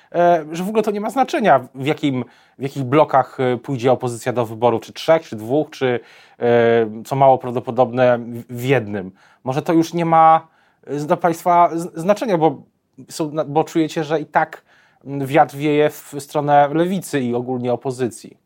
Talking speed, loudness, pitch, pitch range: 155 wpm, -18 LUFS, 140 Hz, 125-160 Hz